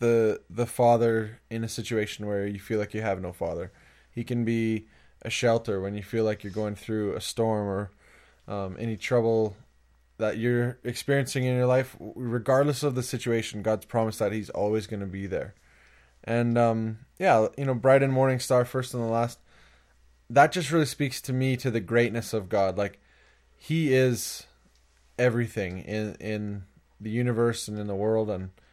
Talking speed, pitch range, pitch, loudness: 185 wpm, 100-120 Hz, 110 Hz, -27 LUFS